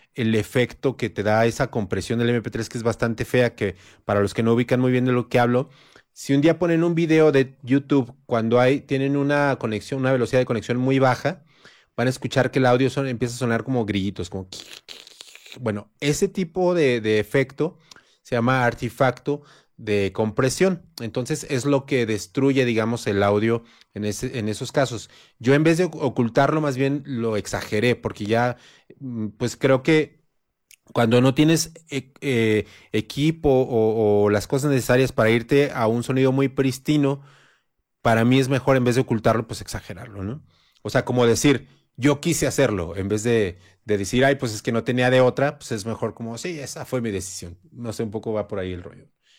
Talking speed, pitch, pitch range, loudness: 195 wpm, 125 Hz, 110-140 Hz, -22 LUFS